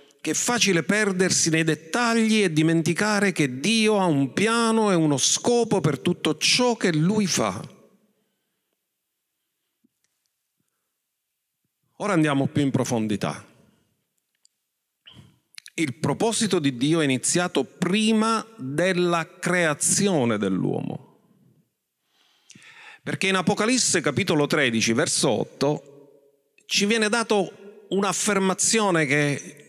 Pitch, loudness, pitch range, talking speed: 175 Hz, -22 LUFS, 150-210 Hz, 95 wpm